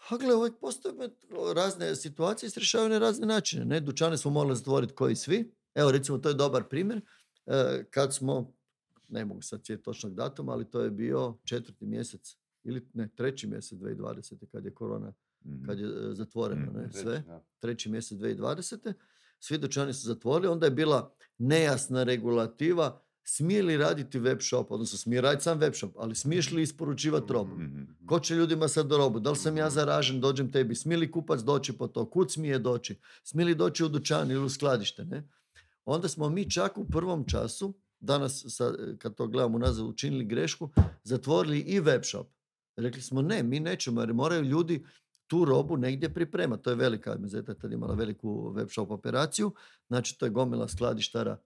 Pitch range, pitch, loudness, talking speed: 120-165 Hz, 140 Hz, -30 LUFS, 180 wpm